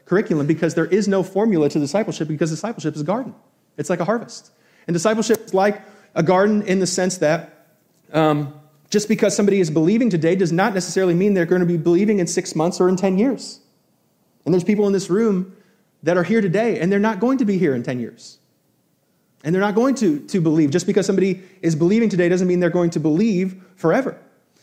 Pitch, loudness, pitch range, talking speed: 185 Hz, -19 LUFS, 170-205 Hz, 220 wpm